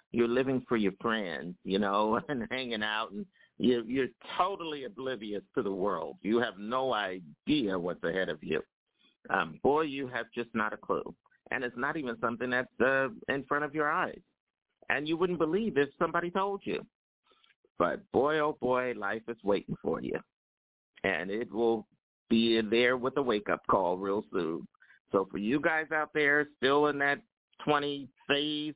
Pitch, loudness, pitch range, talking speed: 130 Hz, -31 LUFS, 115-150 Hz, 180 wpm